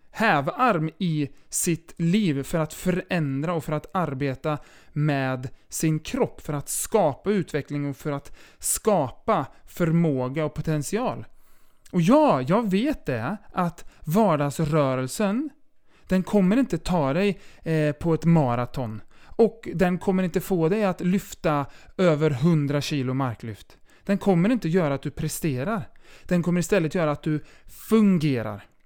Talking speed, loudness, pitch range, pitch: 135 wpm, -24 LUFS, 145-190 Hz, 160 Hz